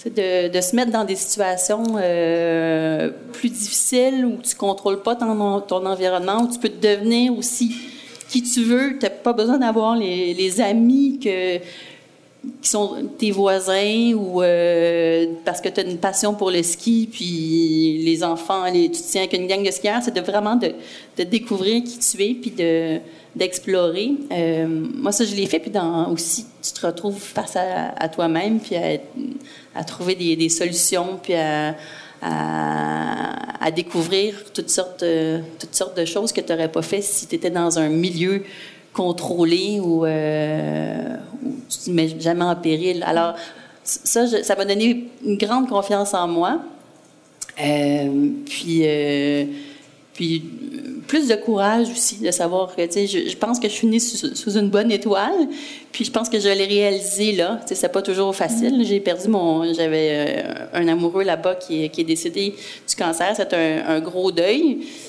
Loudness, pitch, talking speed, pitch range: -20 LUFS, 195 Hz, 180 wpm, 170-230 Hz